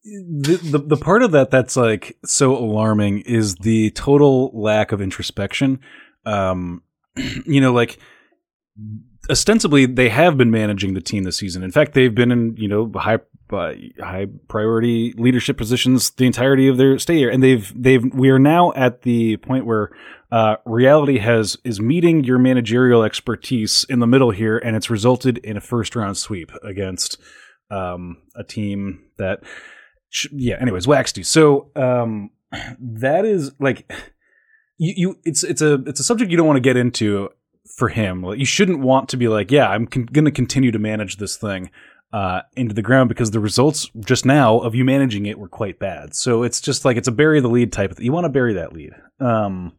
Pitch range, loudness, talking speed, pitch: 110-135 Hz, -17 LUFS, 195 wpm, 120 Hz